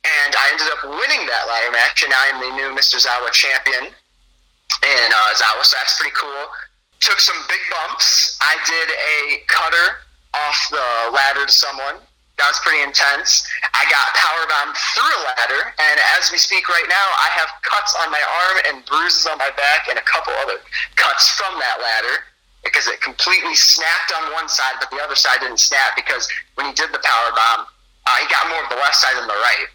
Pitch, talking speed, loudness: 135 Hz, 205 wpm, -15 LUFS